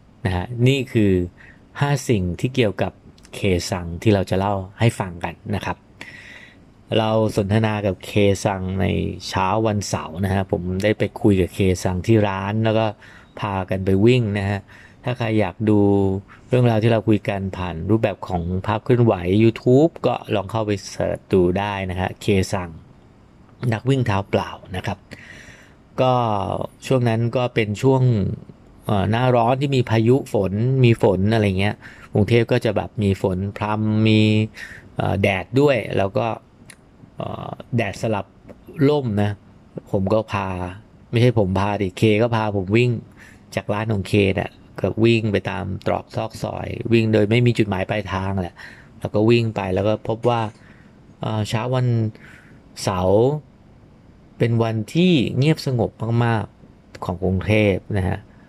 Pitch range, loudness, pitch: 100-115 Hz, -20 LUFS, 105 Hz